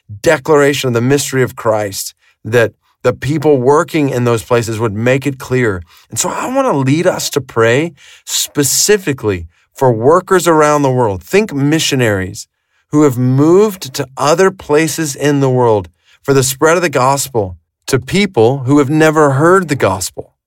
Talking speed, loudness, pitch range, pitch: 165 wpm, -12 LUFS, 120-155 Hz, 140 Hz